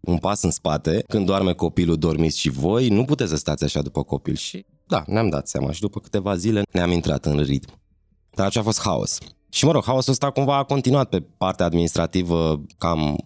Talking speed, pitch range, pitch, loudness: 215 wpm, 75-105 Hz, 85 Hz, -22 LUFS